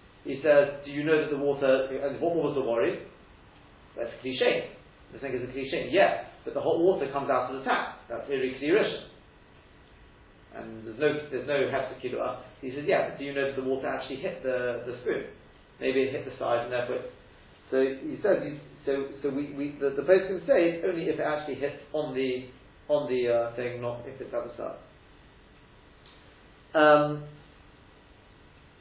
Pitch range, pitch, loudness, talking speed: 130-150 Hz, 140 Hz, -28 LUFS, 195 wpm